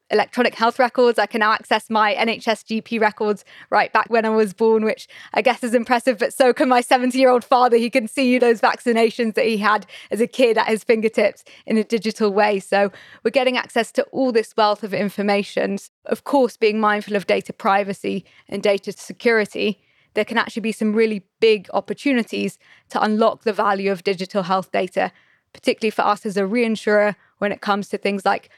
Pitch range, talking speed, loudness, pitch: 205-235 Hz, 205 wpm, -19 LUFS, 220 Hz